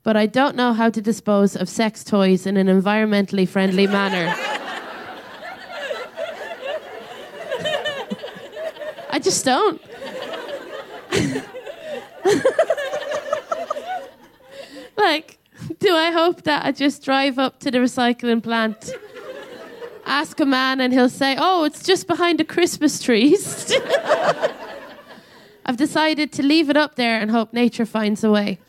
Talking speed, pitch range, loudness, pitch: 120 wpm, 225-320 Hz, -20 LUFS, 275 Hz